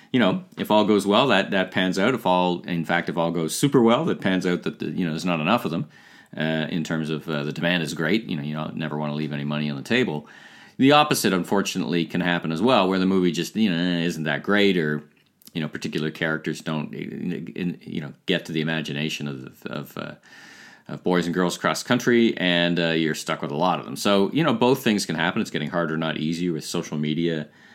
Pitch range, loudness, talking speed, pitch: 80-90 Hz, -23 LUFS, 245 wpm, 85 Hz